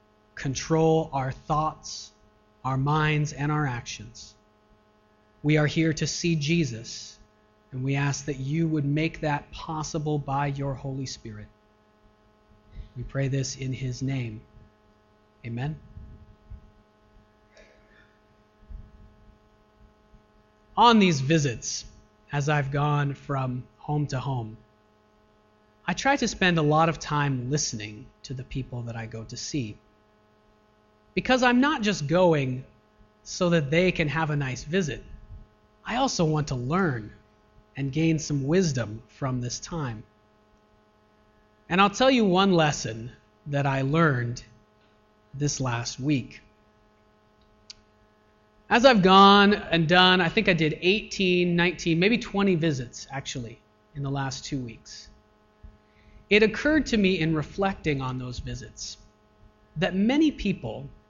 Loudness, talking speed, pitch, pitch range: -25 LUFS, 130 wpm, 130 Hz, 105-155 Hz